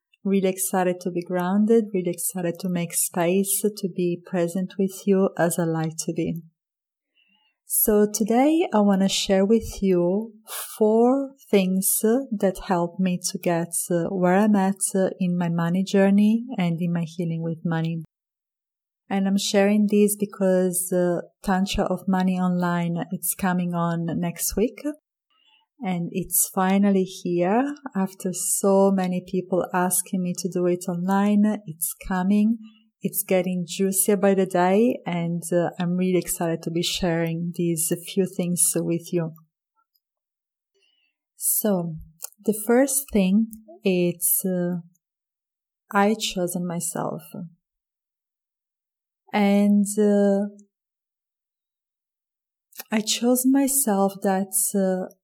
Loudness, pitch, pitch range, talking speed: -23 LUFS, 190 Hz, 175-210 Hz, 125 wpm